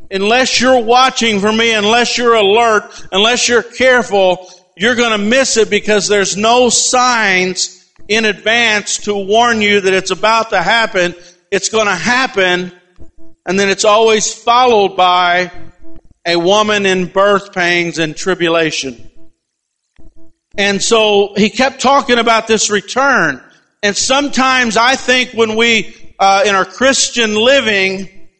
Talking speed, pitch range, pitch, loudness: 140 wpm, 185-235 Hz, 210 Hz, -11 LUFS